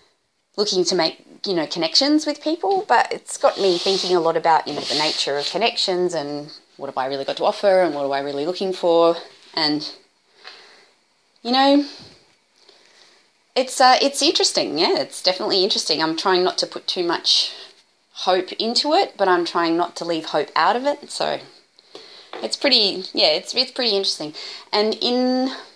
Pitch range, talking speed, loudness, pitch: 170-255 Hz, 180 wpm, -19 LUFS, 190 Hz